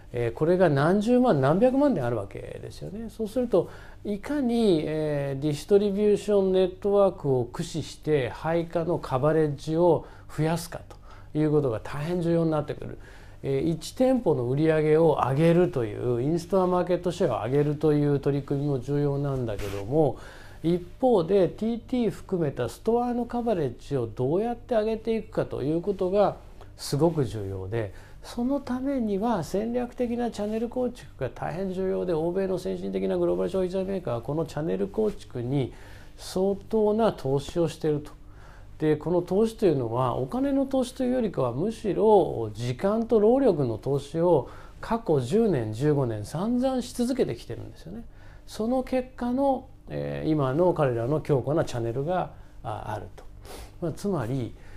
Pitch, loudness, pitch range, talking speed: 165 Hz, -26 LUFS, 135-210 Hz, 340 characters per minute